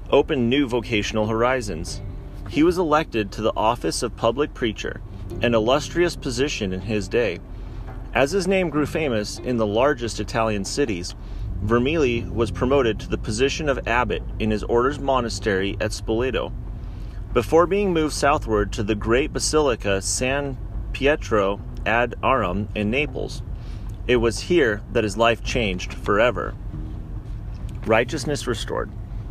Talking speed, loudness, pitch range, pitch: 135 wpm, -22 LUFS, 105-135 Hz, 115 Hz